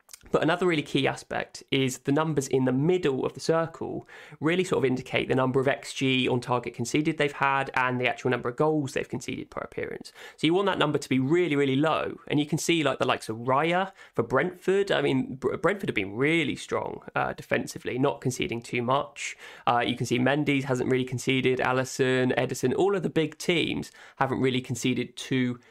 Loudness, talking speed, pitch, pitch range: -27 LUFS, 210 wpm, 135 Hz, 125-150 Hz